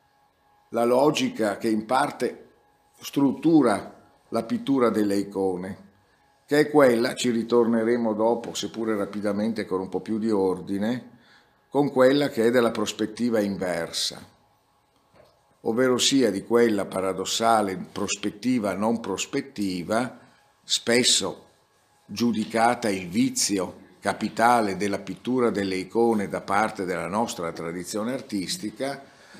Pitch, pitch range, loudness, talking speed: 110 Hz, 100-120 Hz, -24 LUFS, 110 wpm